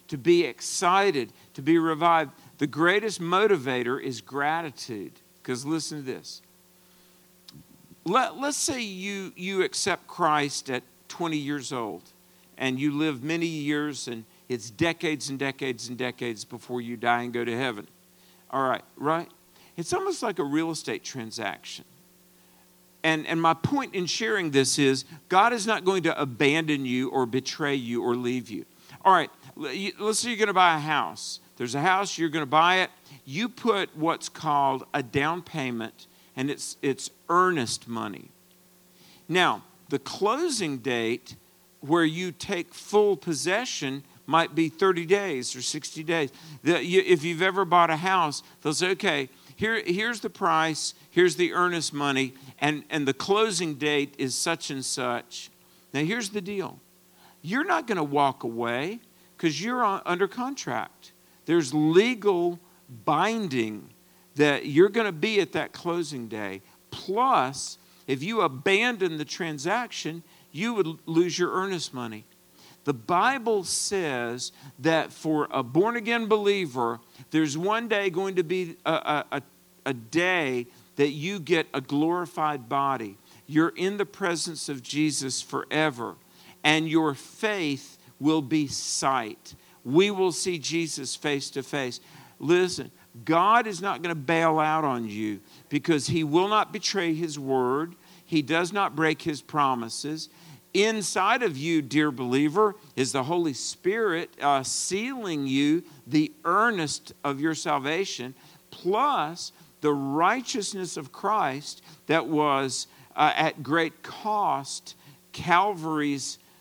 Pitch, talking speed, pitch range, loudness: 155 Hz, 145 wpm, 135-180 Hz, -26 LUFS